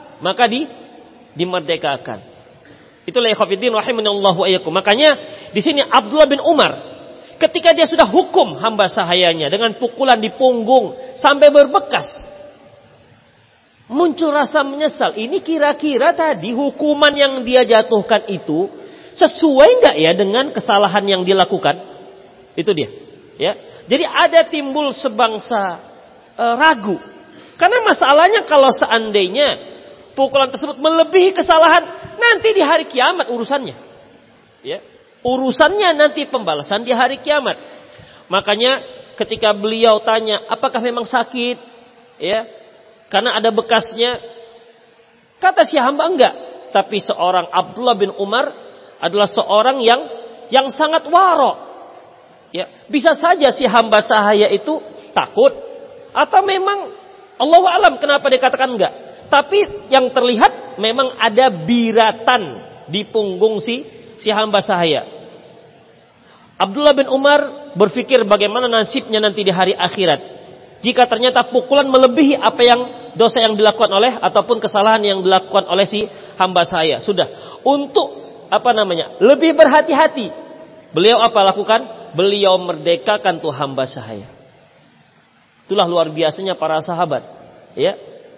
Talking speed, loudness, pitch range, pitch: 120 wpm, -14 LUFS, 210-300 Hz, 245 Hz